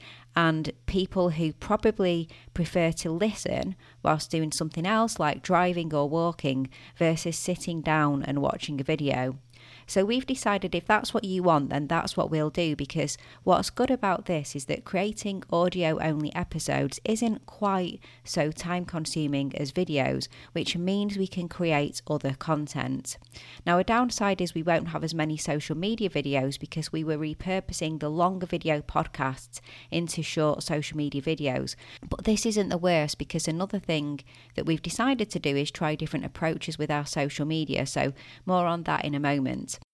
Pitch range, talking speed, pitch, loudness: 145-180 Hz, 170 wpm, 160 Hz, -28 LUFS